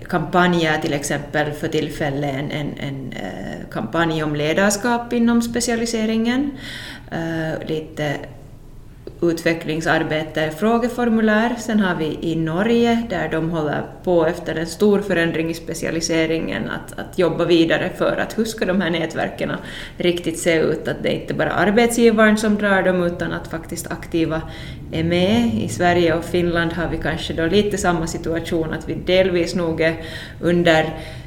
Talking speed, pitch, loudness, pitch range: 150 wpm, 165 Hz, -20 LUFS, 160-190 Hz